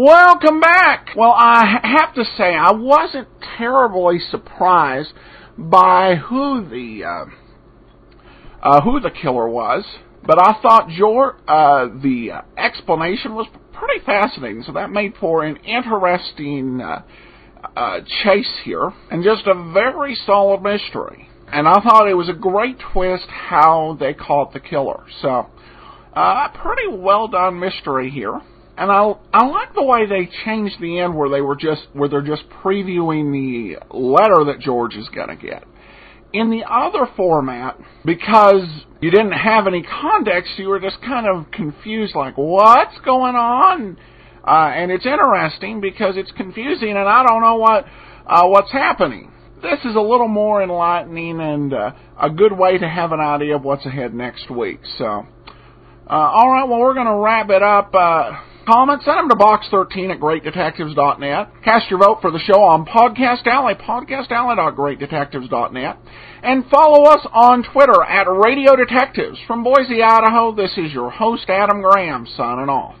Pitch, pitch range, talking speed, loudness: 200 Hz, 160-235 Hz, 160 wpm, -15 LUFS